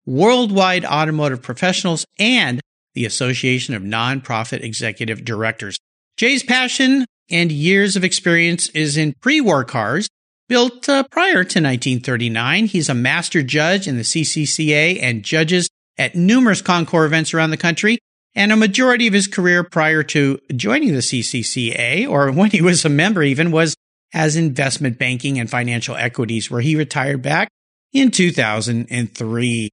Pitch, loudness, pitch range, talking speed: 155 Hz, -16 LUFS, 125-185 Hz, 145 wpm